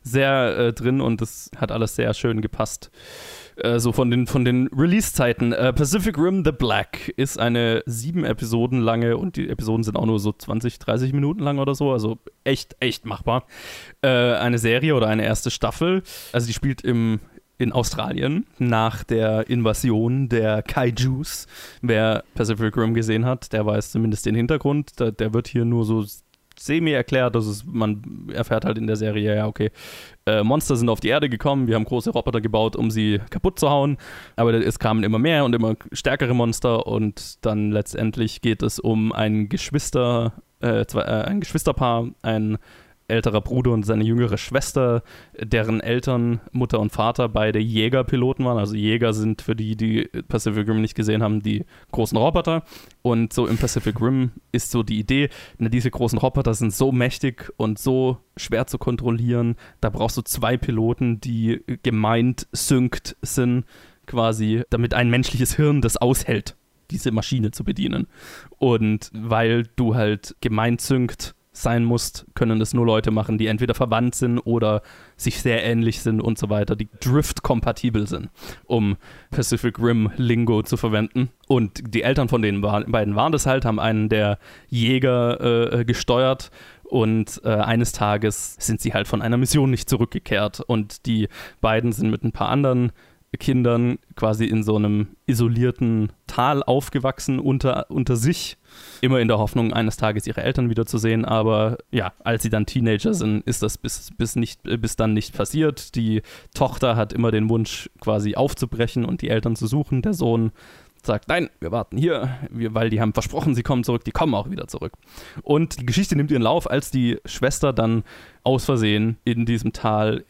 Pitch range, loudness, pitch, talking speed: 110-130 Hz, -22 LUFS, 115 Hz, 175 wpm